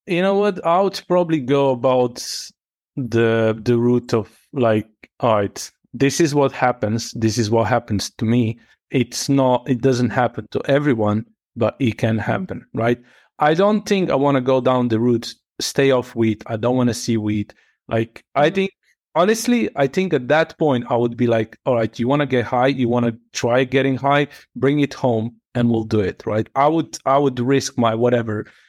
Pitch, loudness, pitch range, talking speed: 125 Hz, -19 LUFS, 115-140 Hz, 205 wpm